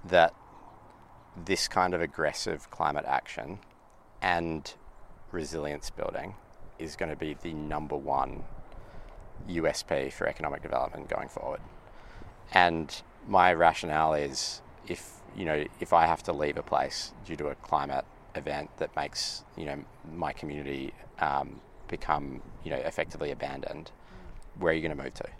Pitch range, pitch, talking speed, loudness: 75-90 Hz, 80 Hz, 145 wpm, -31 LUFS